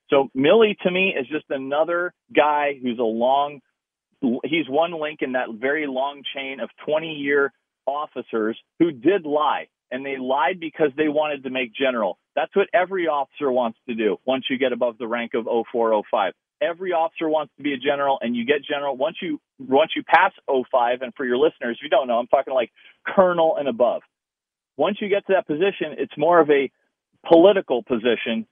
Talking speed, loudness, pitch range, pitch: 200 wpm, -22 LUFS, 130-165 Hz, 145 Hz